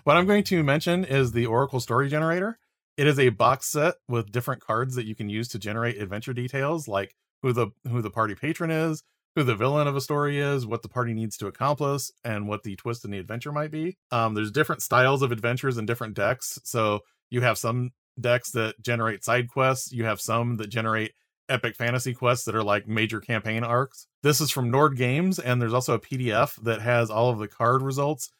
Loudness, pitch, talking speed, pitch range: -26 LUFS, 125 Hz, 220 wpm, 115-140 Hz